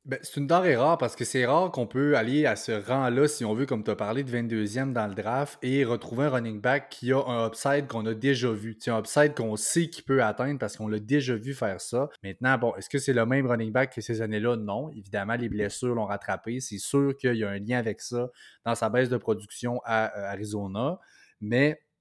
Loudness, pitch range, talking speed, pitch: -27 LUFS, 110-135 Hz, 245 wpm, 120 Hz